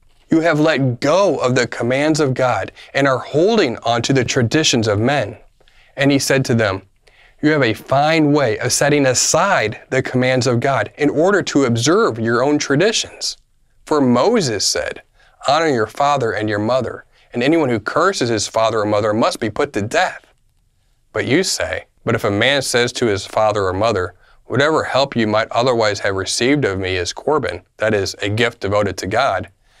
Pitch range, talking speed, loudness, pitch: 110-140 Hz, 190 wpm, -17 LUFS, 125 Hz